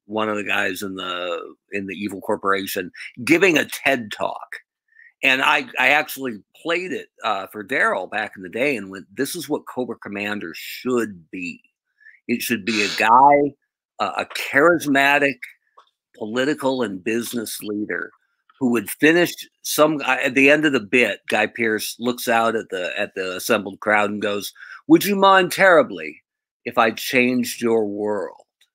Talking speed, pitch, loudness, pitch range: 165 wpm, 125 Hz, -20 LUFS, 105-150 Hz